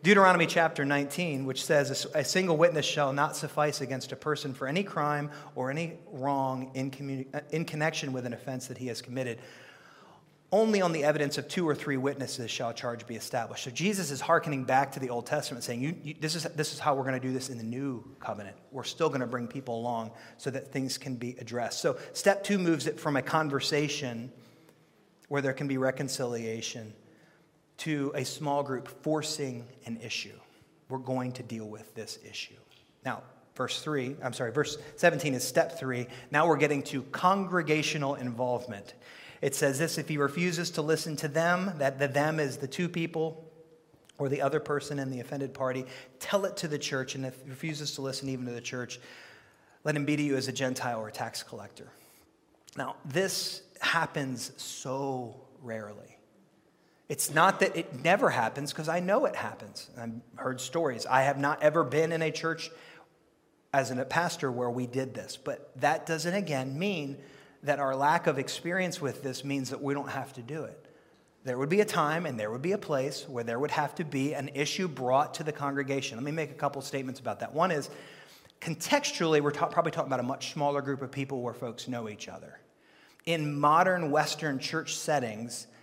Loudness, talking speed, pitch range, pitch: -31 LUFS, 200 wpm, 130-160 Hz, 140 Hz